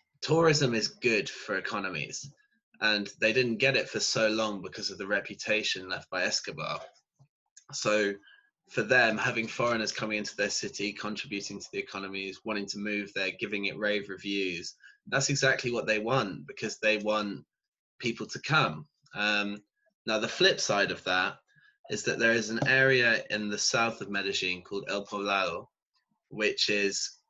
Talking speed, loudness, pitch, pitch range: 165 wpm, -29 LUFS, 110 Hz, 100-130 Hz